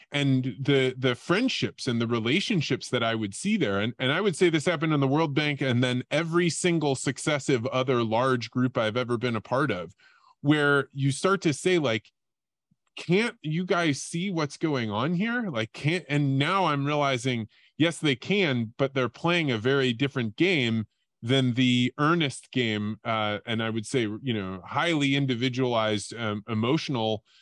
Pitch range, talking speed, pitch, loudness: 120-155 Hz, 180 wpm, 135 Hz, -26 LUFS